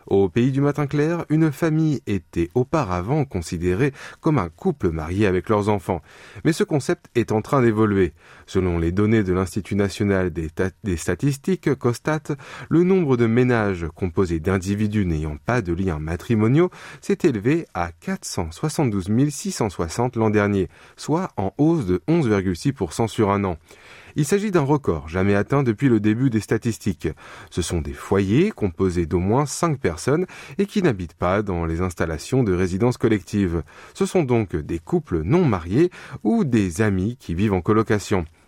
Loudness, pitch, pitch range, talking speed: -22 LUFS, 110 Hz, 95-145 Hz, 165 wpm